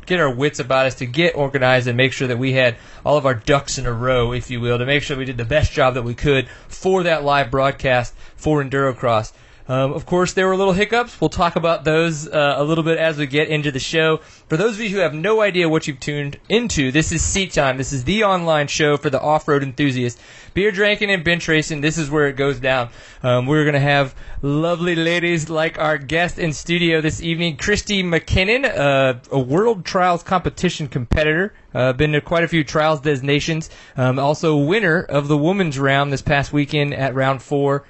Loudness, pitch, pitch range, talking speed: -18 LUFS, 150 Hz, 135-165 Hz, 225 wpm